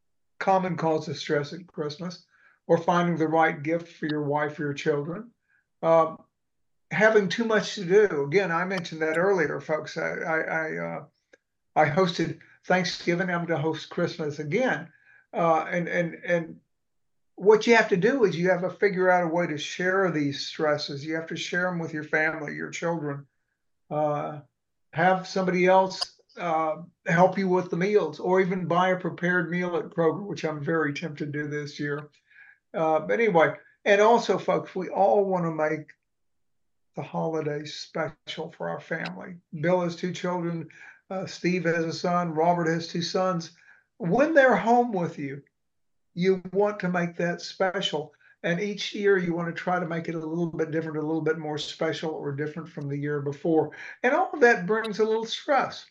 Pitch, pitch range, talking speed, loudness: 170 Hz, 155-185 Hz, 185 wpm, -26 LUFS